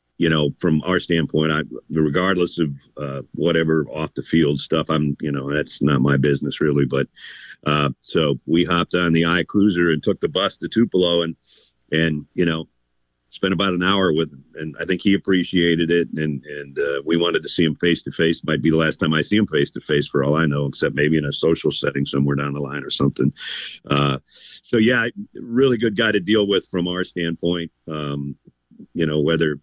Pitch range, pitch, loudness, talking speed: 70-85 Hz, 80 Hz, -20 LUFS, 215 wpm